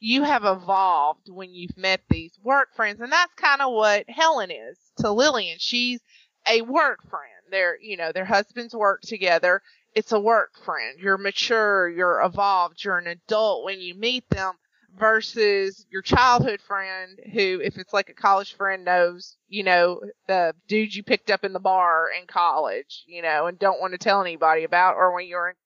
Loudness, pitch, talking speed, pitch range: -22 LUFS, 195 Hz, 190 wpm, 180-225 Hz